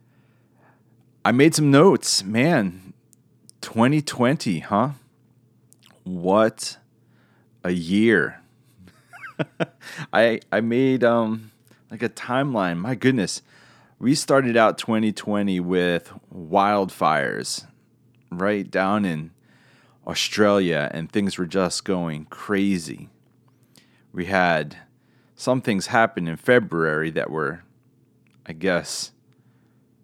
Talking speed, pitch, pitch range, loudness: 90 wpm, 110 Hz, 90-120 Hz, -22 LUFS